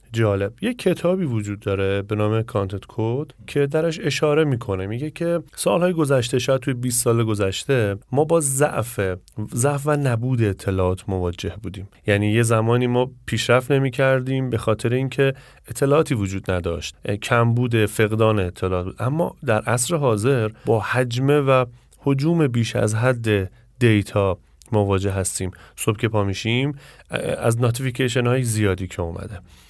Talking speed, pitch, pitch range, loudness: 145 wpm, 115 Hz, 100-135 Hz, -21 LUFS